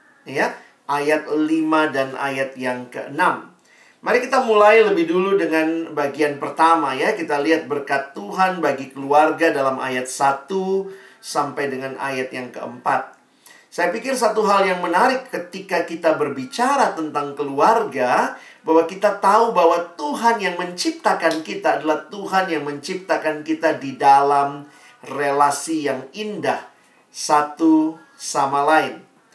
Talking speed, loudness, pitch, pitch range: 125 wpm, -19 LUFS, 160 Hz, 140-190 Hz